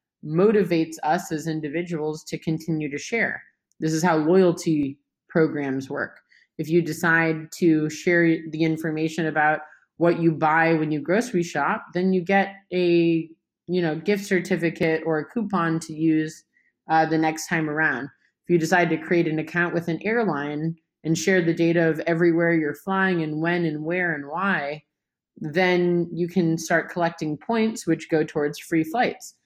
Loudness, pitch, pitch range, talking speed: -23 LUFS, 165 Hz, 155-175 Hz, 165 wpm